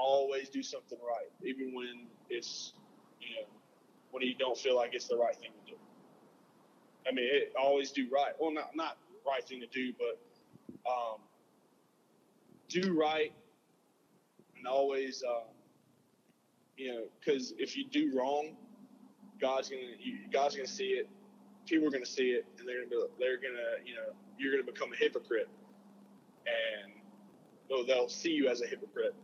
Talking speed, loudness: 165 wpm, -36 LUFS